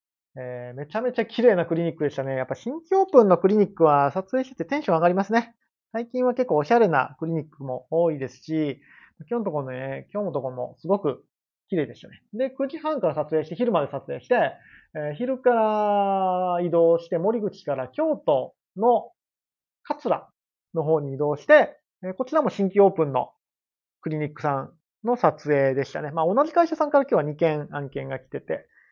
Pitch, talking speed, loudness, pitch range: 170 Hz, 365 characters per minute, -24 LUFS, 145-230 Hz